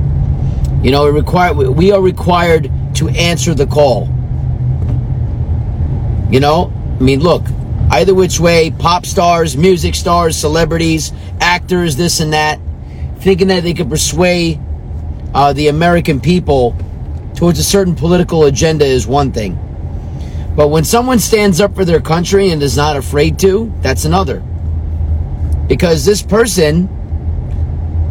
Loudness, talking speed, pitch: -12 LUFS, 135 wpm, 145 Hz